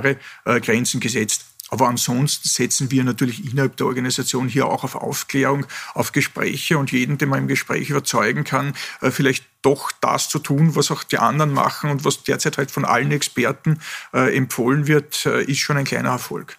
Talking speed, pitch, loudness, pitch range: 175 wpm, 140 Hz, -20 LUFS, 130-145 Hz